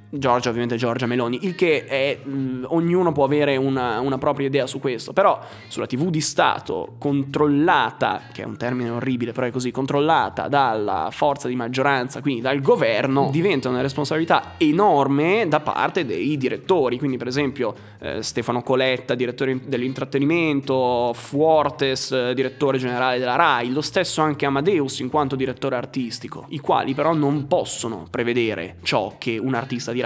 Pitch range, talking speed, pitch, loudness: 125-145 Hz, 160 wpm, 135 Hz, -21 LUFS